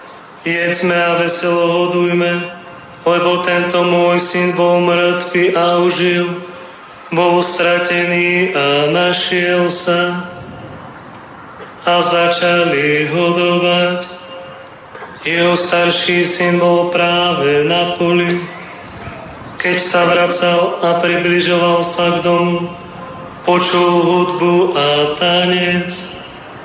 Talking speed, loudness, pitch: 90 wpm, -13 LUFS, 175 Hz